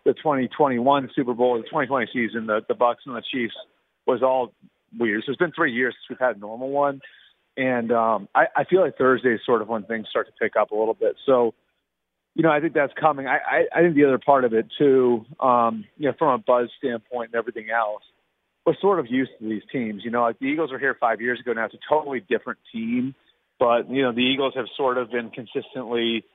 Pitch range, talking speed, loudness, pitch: 115-135 Hz, 245 wpm, -23 LUFS, 125 Hz